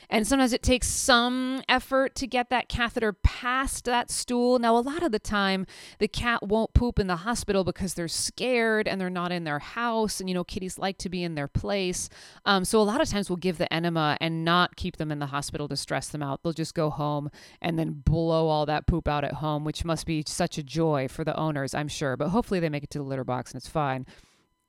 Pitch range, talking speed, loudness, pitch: 150-225 Hz, 250 wpm, -27 LUFS, 180 Hz